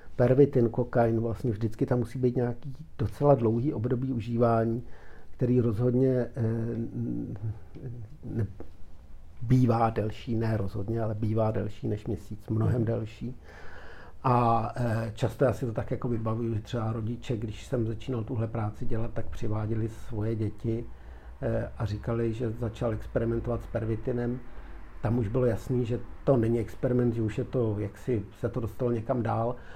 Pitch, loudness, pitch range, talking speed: 115 Hz, -29 LUFS, 110-125 Hz, 155 wpm